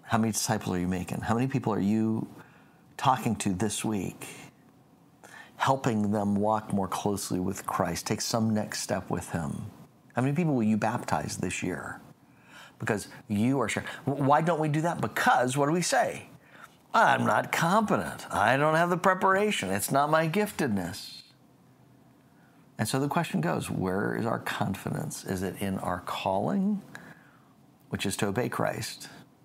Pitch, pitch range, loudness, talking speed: 125 Hz, 105-160 Hz, -28 LUFS, 165 wpm